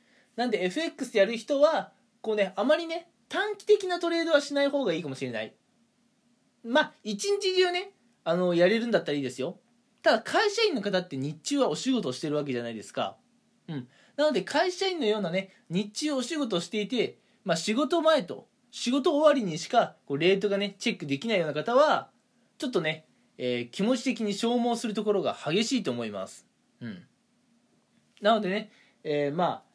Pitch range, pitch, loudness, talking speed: 190-285 Hz, 230 Hz, -28 LUFS, 370 characters per minute